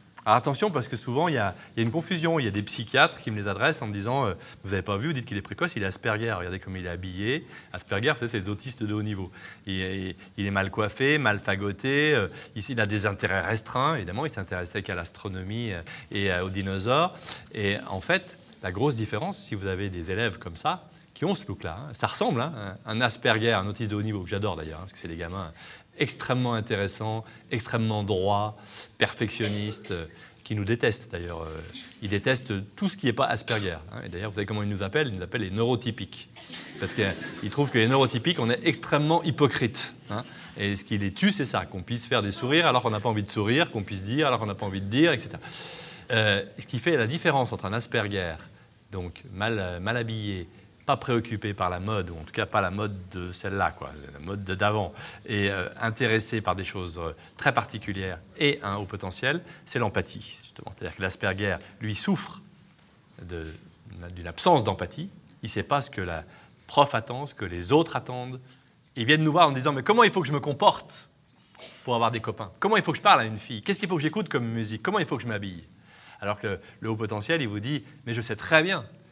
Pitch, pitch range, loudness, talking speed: 110 Hz, 100-135 Hz, -27 LUFS, 235 wpm